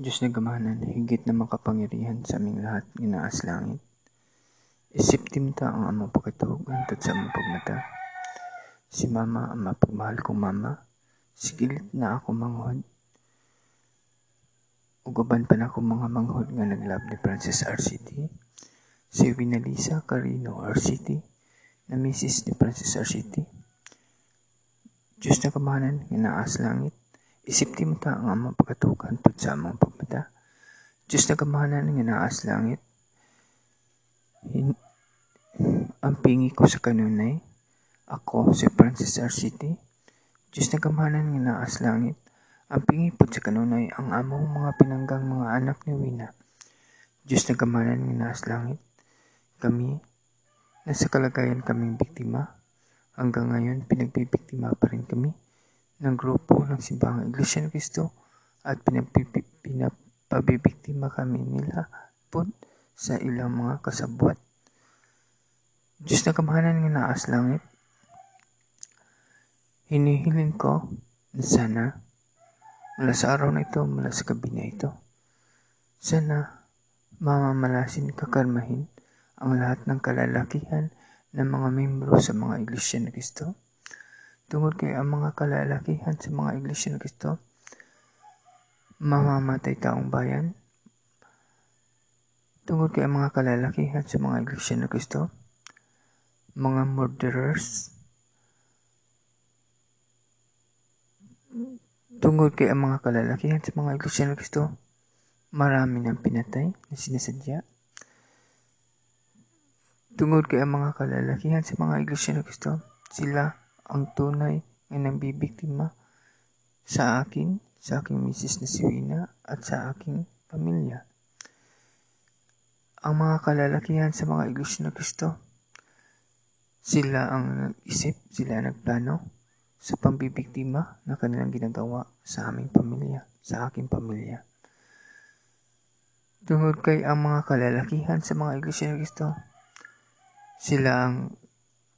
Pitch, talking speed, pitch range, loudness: 130 Hz, 120 wpm, 120-150 Hz, -26 LUFS